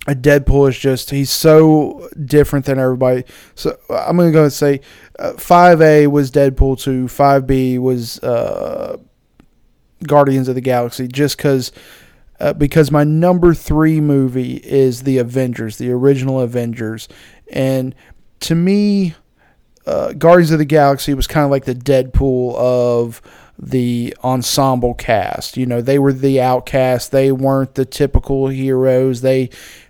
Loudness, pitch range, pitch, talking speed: -14 LUFS, 125-145 Hz, 135 Hz, 145 wpm